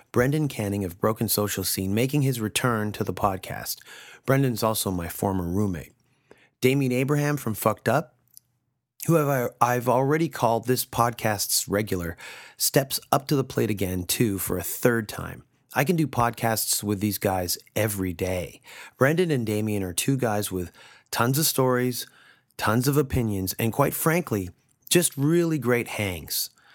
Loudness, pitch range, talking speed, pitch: -25 LUFS, 100-135 Hz, 155 wpm, 115 Hz